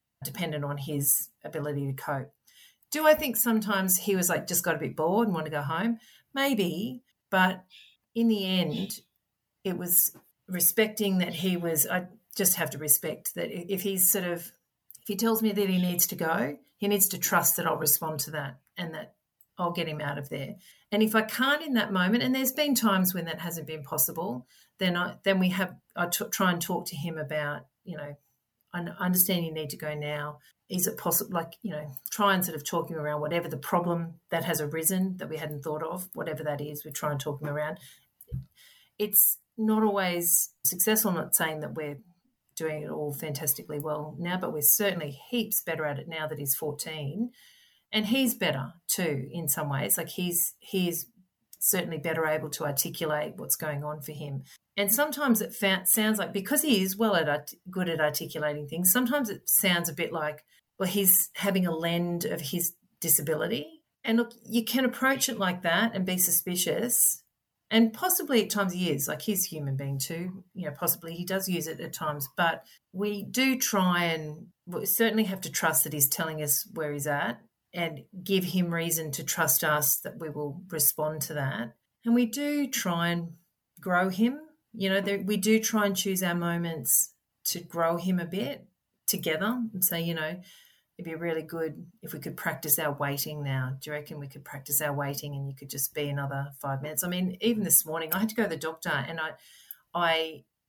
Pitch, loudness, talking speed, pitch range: 170 Hz, -28 LUFS, 205 wpm, 155-200 Hz